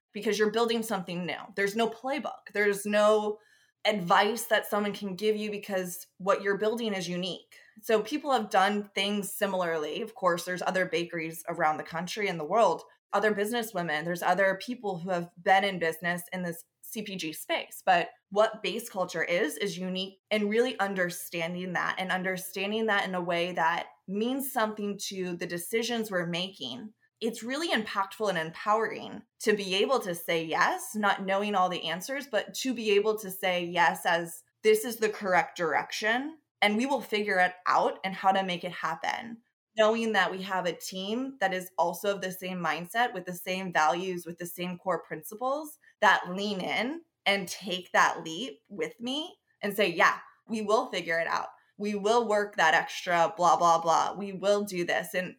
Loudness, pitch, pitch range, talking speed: -29 LUFS, 195 Hz, 180-215 Hz, 185 wpm